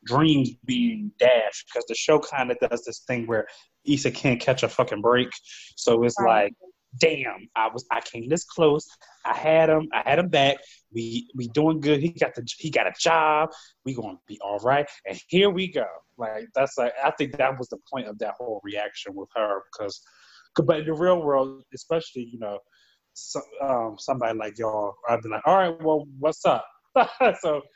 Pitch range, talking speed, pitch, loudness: 120-160 Hz, 200 wpm, 140 Hz, -24 LUFS